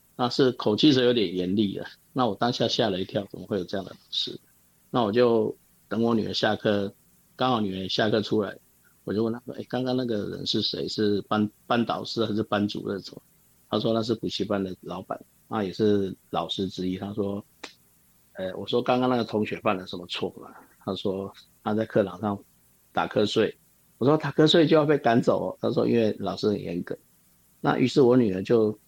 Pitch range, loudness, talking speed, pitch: 95-115 Hz, -26 LUFS, 295 characters per minute, 105 Hz